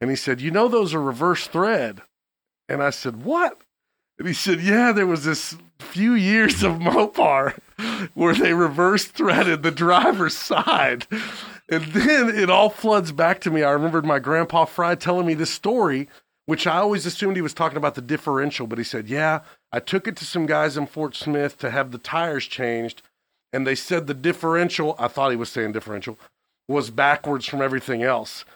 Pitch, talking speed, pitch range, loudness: 160 Hz, 195 wpm, 135-180 Hz, -21 LUFS